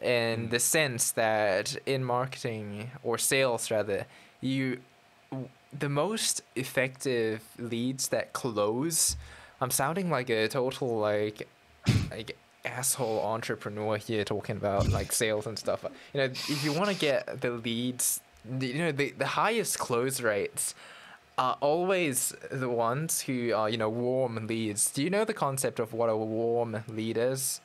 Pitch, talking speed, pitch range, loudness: 120 Hz, 150 wpm, 110-135 Hz, -30 LUFS